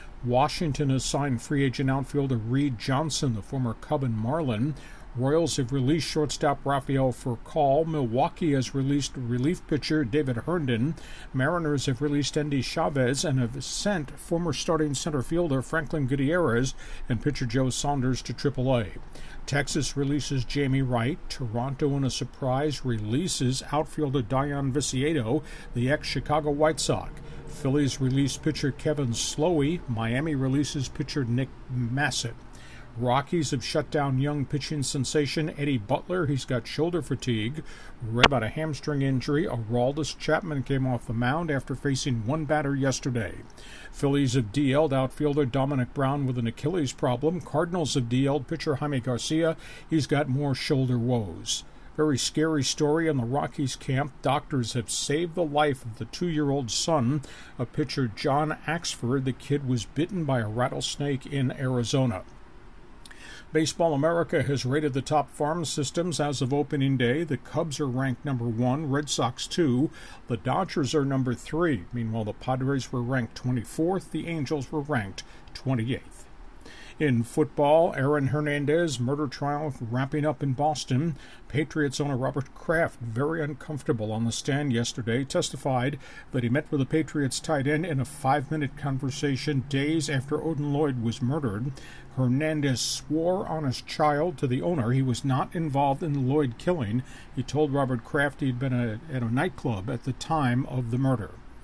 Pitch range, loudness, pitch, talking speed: 125-150 Hz, -27 LUFS, 140 Hz, 155 wpm